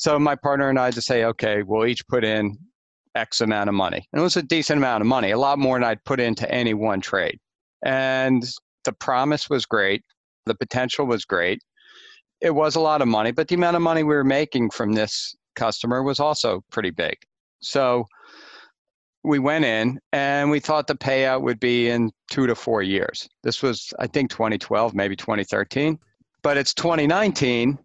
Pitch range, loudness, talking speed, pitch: 115-150 Hz, -22 LUFS, 195 wpm, 130 Hz